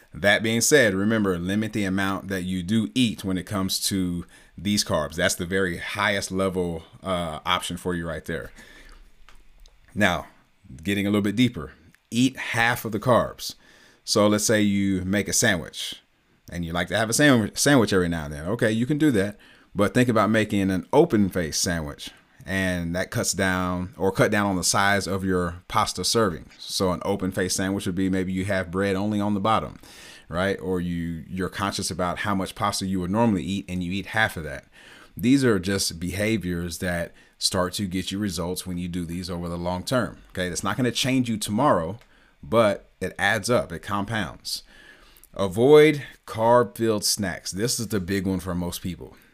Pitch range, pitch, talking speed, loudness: 90-105 Hz, 95 Hz, 195 wpm, -24 LUFS